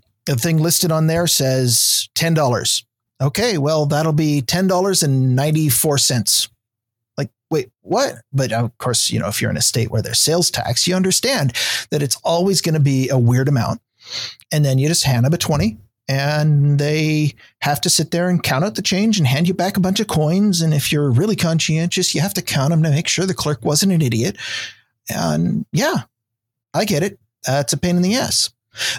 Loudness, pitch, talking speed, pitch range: -17 LUFS, 150 Hz, 210 wpm, 125-170 Hz